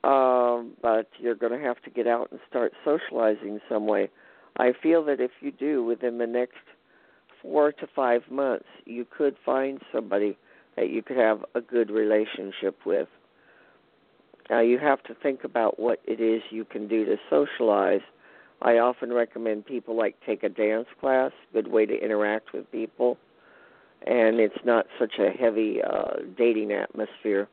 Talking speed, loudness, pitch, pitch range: 170 wpm, -26 LUFS, 115 Hz, 110-125 Hz